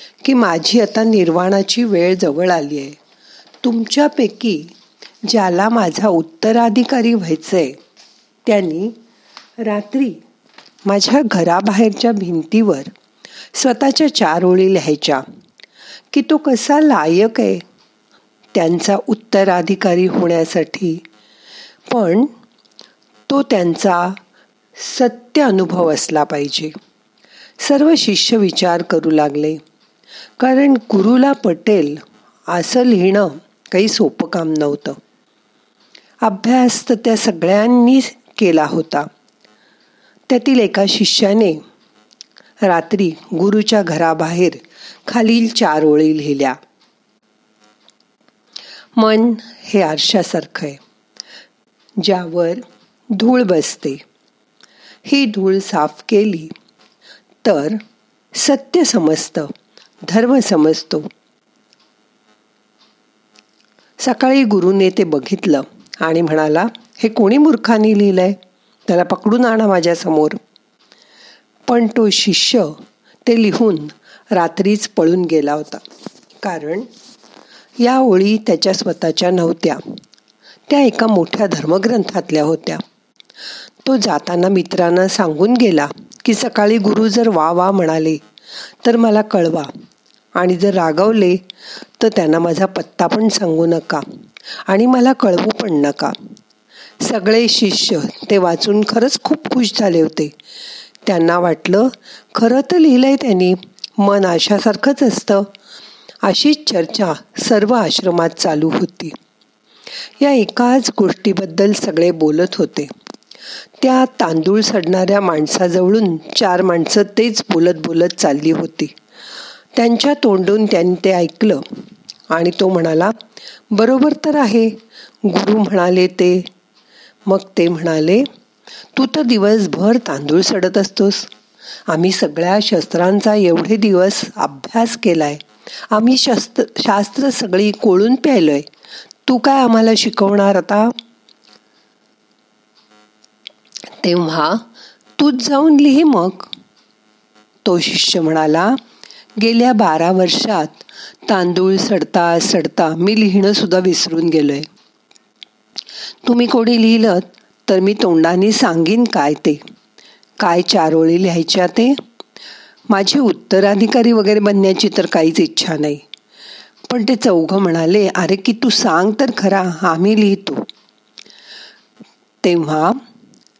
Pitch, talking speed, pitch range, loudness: 195 Hz, 95 wpm, 170-230 Hz, -14 LUFS